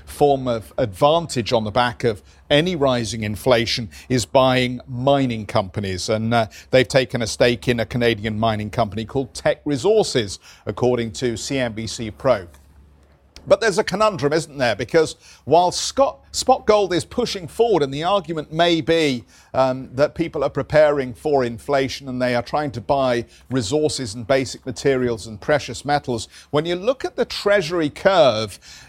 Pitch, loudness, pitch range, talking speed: 130 Hz, -20 LUFS, 115-150 Hz, 160 wpm